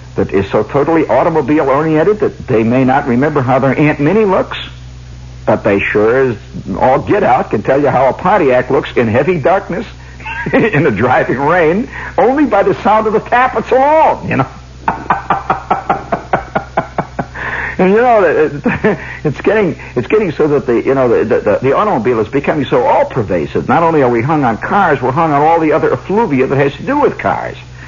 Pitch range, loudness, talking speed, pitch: 130-215 Hz, -12 LUFS, 185 wpm, 155 Hz